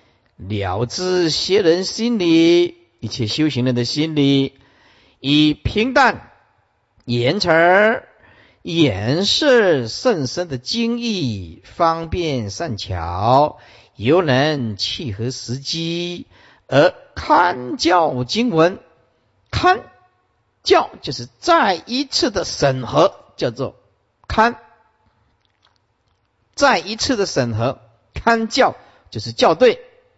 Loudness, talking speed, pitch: -18 LUFS, 130 characters per minute, 150 Hz